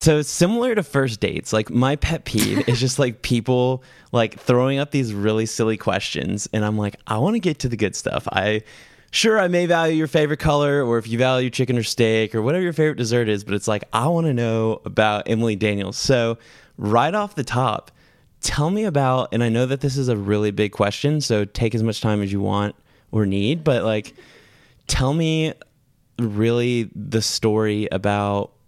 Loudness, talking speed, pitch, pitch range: -21 LUFS, 205 wpm, 120 Hz, 110-140 Hz